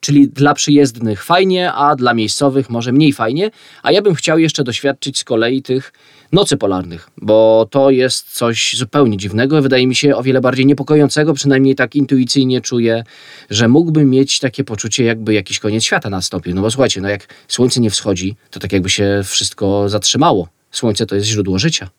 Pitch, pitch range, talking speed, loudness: 125 Hz, 105-140 Hz, 185 wpm, -13 LUFS